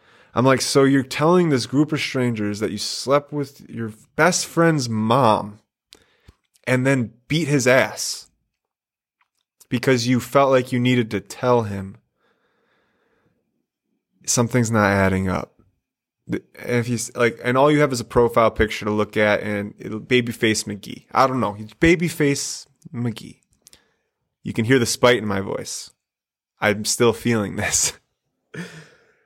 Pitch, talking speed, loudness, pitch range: 120 Hz, 150 wpm, -20 LUFS, 110-135 Hz